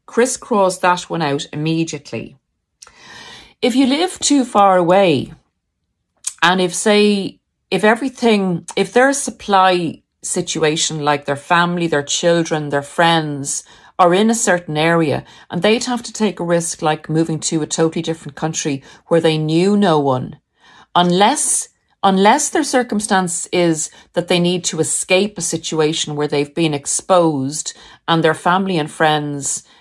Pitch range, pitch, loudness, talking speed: 155-200 Hz, 175 Hz, -16 LUFS, 145 wpm